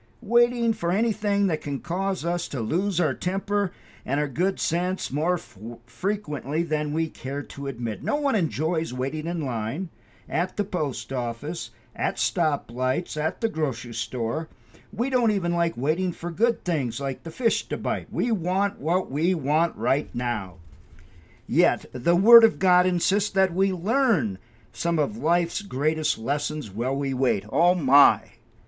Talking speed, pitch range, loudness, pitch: 165 wpm, 130-190 Hz, -25 LUFS, 165 Hz